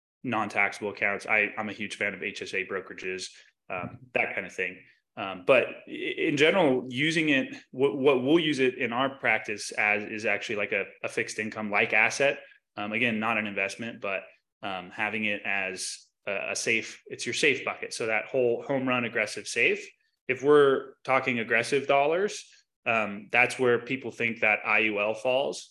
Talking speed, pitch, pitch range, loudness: 180 wpm, 120 Hz, 105-140 Hz, -27 LUFS